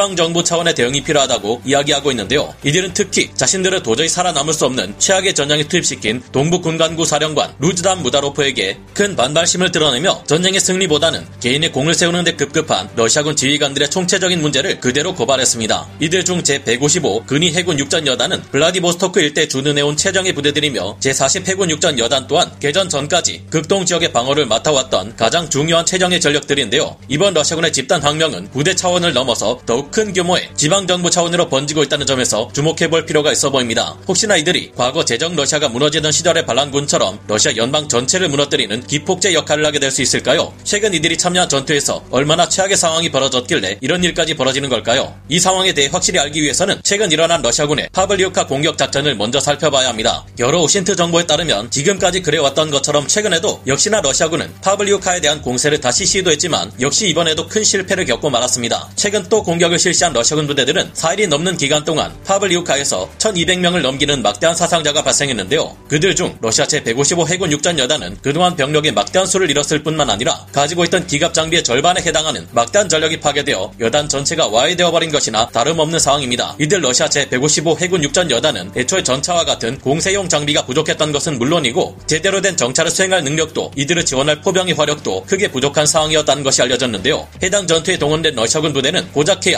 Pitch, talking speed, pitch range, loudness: 155 Hz, 460 characters per minute, 140-180 Hz, -14 LUFS